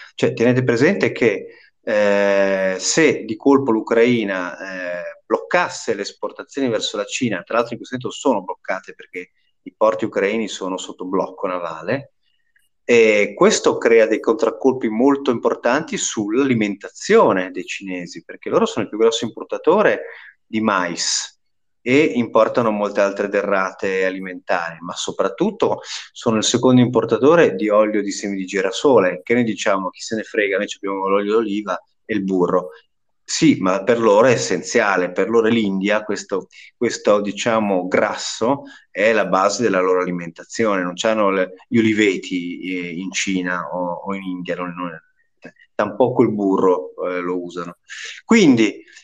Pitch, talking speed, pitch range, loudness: 110 Hz, 150 wpm, 95-140 Hz, -18 LUFS